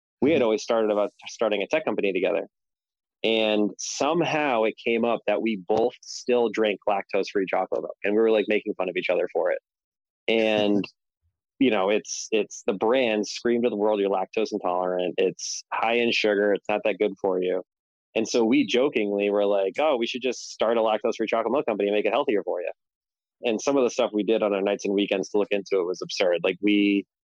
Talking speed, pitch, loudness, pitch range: 220 wpm, 105 Hz, -24 LUFS, 100-115 Hz